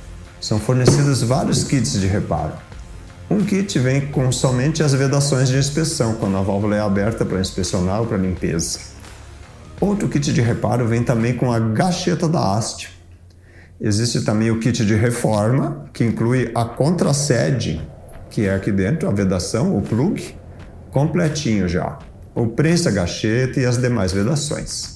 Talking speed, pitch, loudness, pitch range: 150 wpm, 115 Hz, -19 LUFS, 95-135 Hz